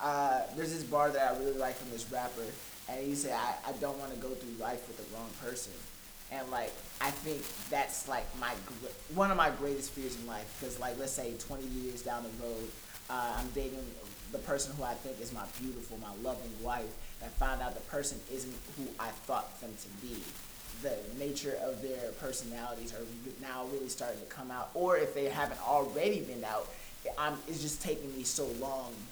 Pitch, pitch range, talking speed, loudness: 130 Hz, 120-140 Hz, 215 wpm, -37 LUFS